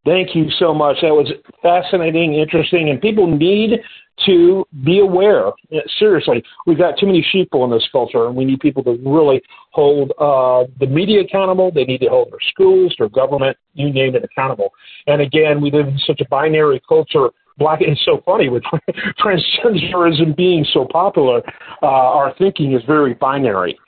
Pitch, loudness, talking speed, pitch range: 165 Hz, -14 LUFS, 175 wpm, 145-200 Hz